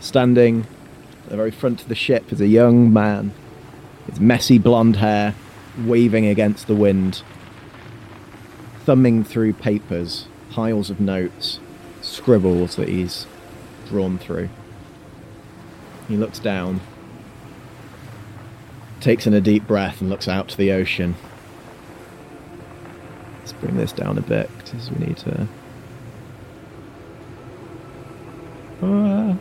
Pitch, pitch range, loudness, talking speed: 110 Hz, 100-120 Hz, -19 LUFS, 115 wpm